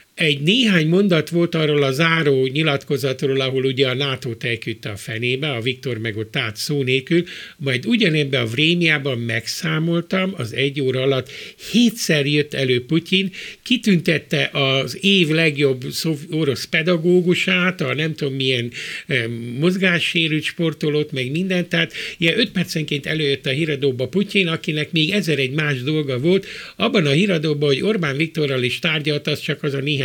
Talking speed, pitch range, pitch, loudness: 155 wpm, 135-170 Hz, 150 Hz, -19 LUFS